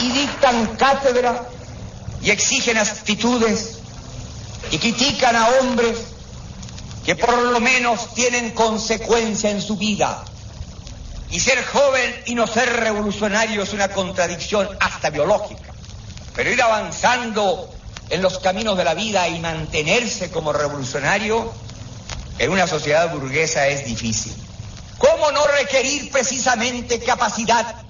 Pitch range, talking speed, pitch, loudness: 160-240 Hz, 120 wpm, 215 Hz, -18 LUFS